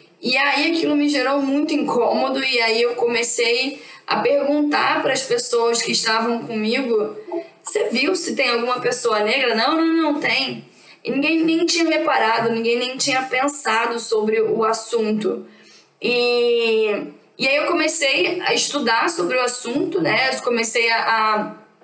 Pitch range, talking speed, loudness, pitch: 230-300 Hz, 155 wpm, -18 LUFS, 255 Hz